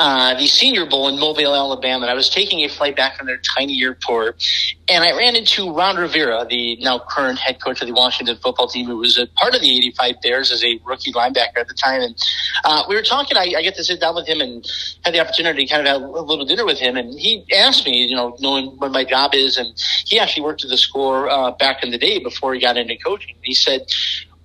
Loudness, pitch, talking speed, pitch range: -16 LUFS, 135 Hz, 260 wpm, 125-155 Hz